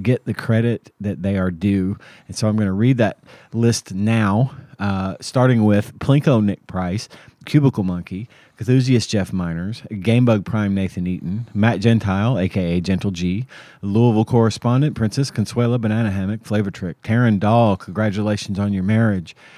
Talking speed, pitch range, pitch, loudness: 155 wpm, 100-120 Hz, 110 Hz, -19 LUFS